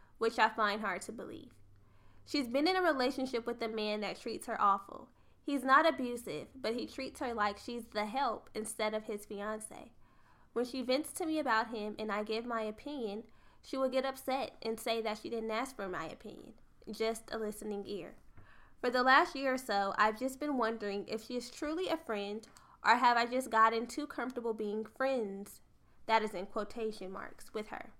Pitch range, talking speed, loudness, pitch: 215-260 Hz, 200 wpm, -35 LUFS, 225 Hz